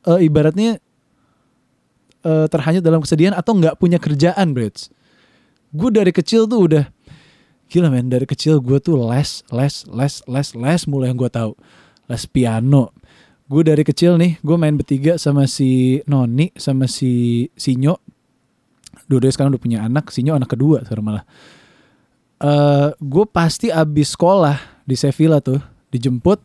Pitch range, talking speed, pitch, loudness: 130-165 Hz, 145 wpm, 145 Hz, -16 LUFS